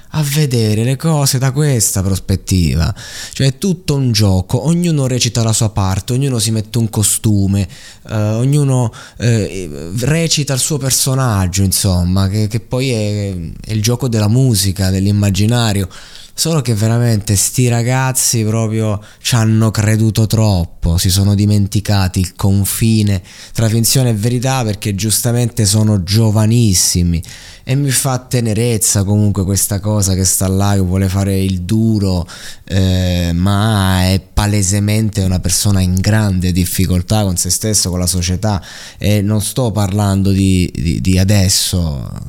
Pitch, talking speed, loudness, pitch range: 105 Hz, 145 wpm, -14 LUFS, 95-120 Hz